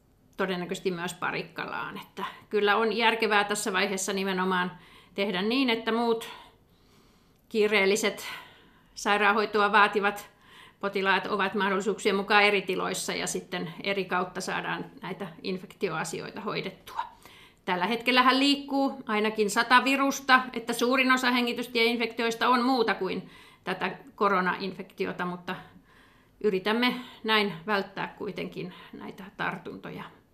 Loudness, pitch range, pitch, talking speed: -27 LUFS, 195-235 Hz, 210 Hz, 105 wpm